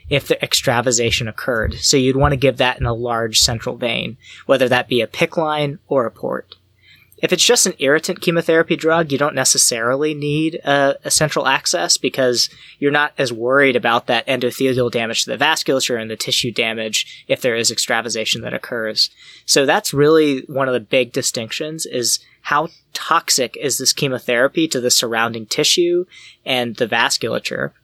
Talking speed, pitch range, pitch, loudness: 175 wpm, 120-155 Hz, 135 Hz, -17 LUFS